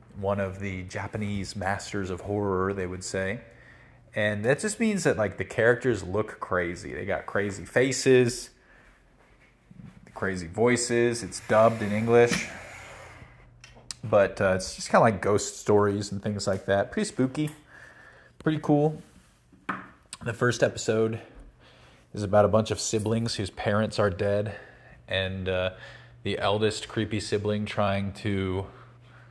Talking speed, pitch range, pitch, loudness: 140 wpm, 100-120 Hz, 105 Hz, -27 LUFS